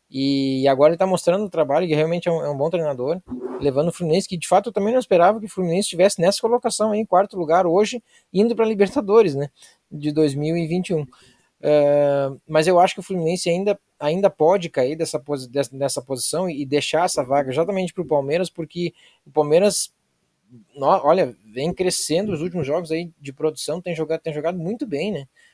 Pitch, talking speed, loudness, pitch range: 170 Hz, 195 wpm, -21 LUFS, 150-190 Hz